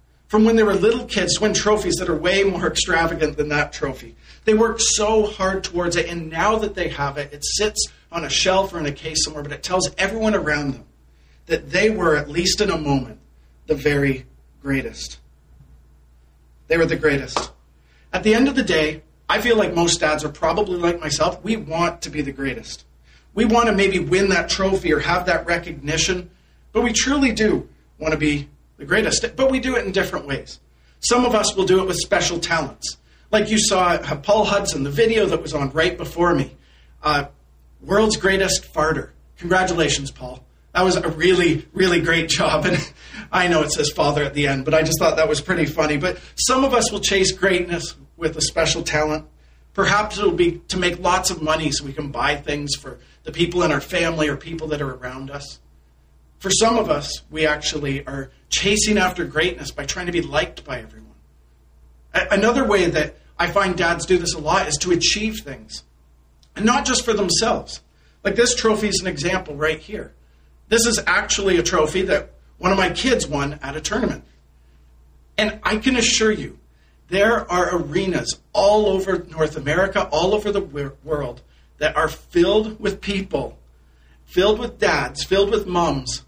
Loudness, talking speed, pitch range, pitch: -20 LUFS, 195 wpm, 145-195 Hz, 170 Hz